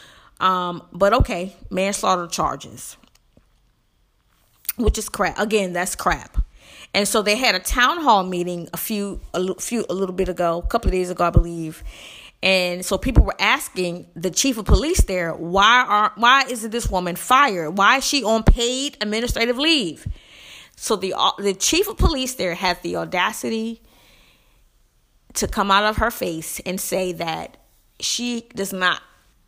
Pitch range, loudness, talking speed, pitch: 180-225 Hz, -20 LUFS, 165 wpm, 190 Hz